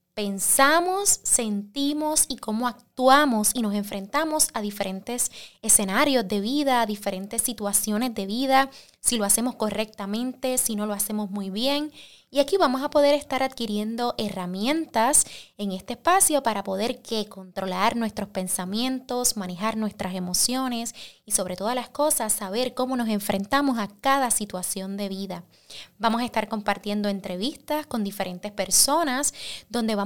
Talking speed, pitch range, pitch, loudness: 145 wpm, 200-260 Hz, 225 Hz, -24 LUFS